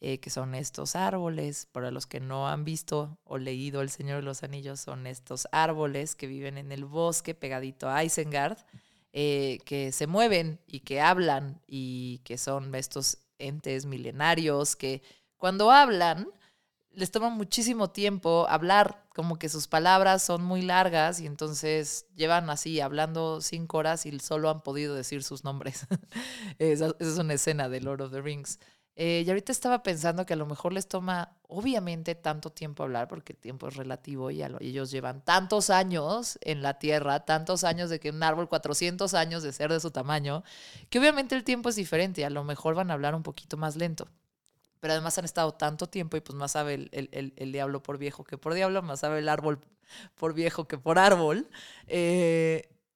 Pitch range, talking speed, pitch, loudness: 140-175 Hz, 195 wpm, 155 Hz, -29 LUFS